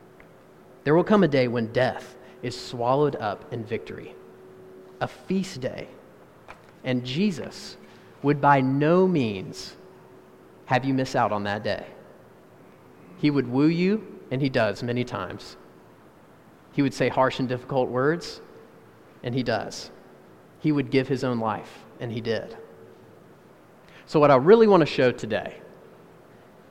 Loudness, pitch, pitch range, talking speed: -24 LUFS, 130 Hz, 115-150 Hz, 145 wpm